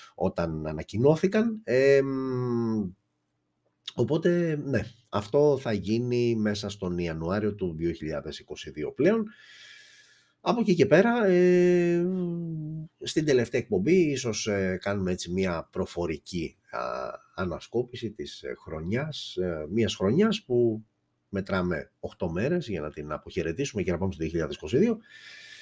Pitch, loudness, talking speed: 120 Hz, -27 LUFS, 110 wpm